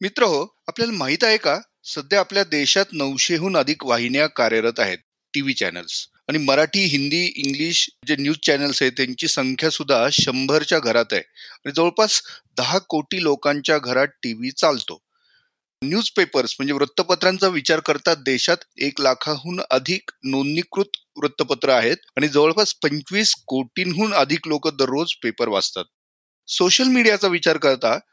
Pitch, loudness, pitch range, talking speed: 155 Hz, -20 LUFS, 140-185 Hz, 135 wpm